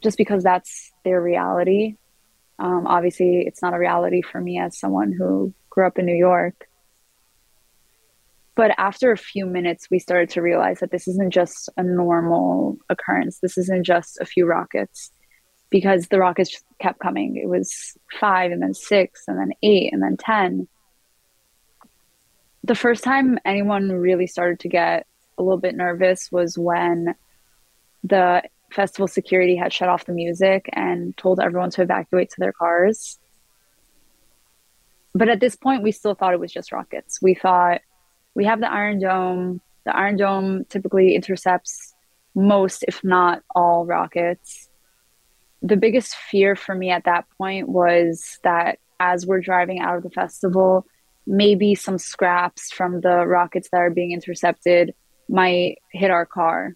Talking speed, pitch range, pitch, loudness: 160 wpm, 175-195 Hz, 180 Hz, -20 LUFS